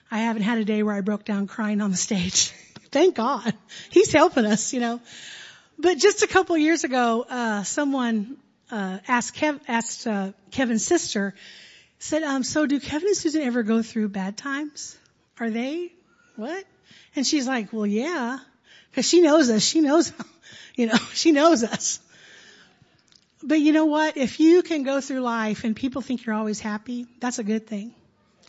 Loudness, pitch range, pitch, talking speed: -23 LUFS, 220-305 Hz, 245 Hz, 185 wpm